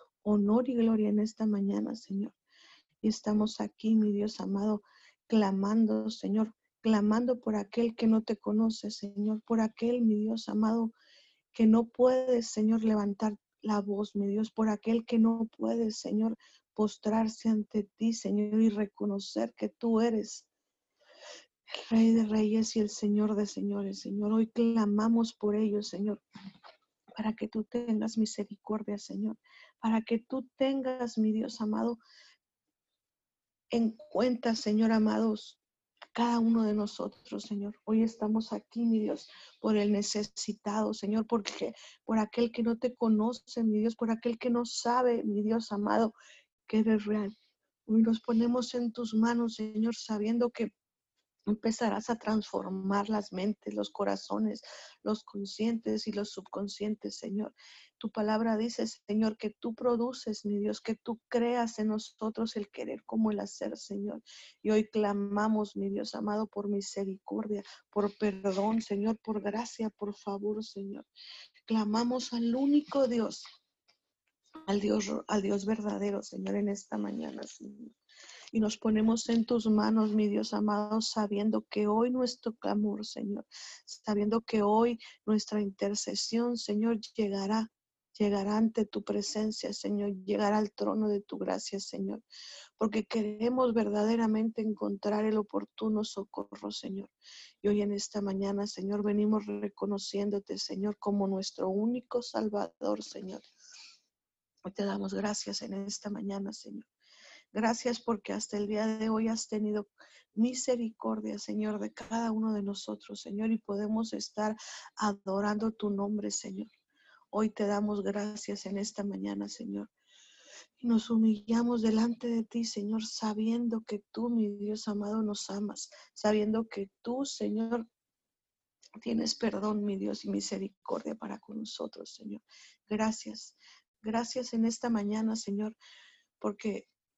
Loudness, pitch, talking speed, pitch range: -32 LUFS, 215 Hz, 140 wpm, 205-230 Hz